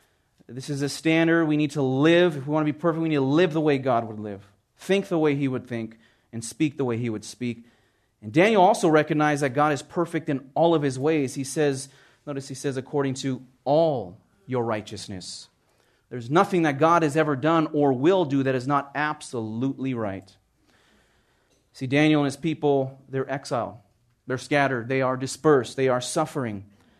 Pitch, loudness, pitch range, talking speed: 135 Hz, -24 LUFS, 120-150 Hz, 200 wpm